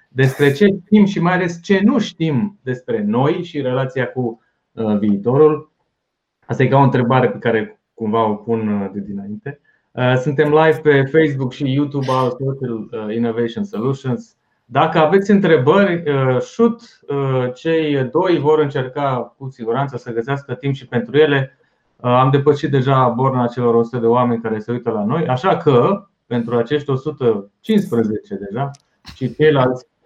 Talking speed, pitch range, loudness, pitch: 150 wpm, 120-155 Hz, -17 LUFS, 135 Hz